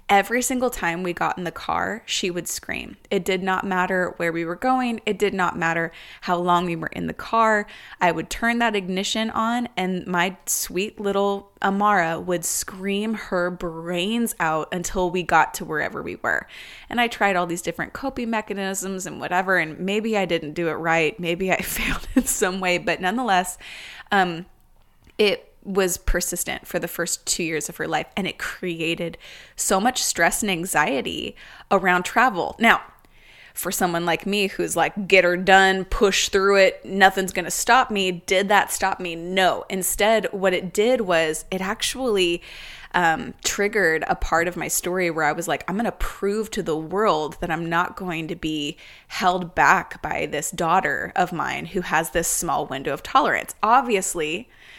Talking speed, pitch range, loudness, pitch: 185 wpm, 175-205 Hz, -22 LUFS, 185 Hz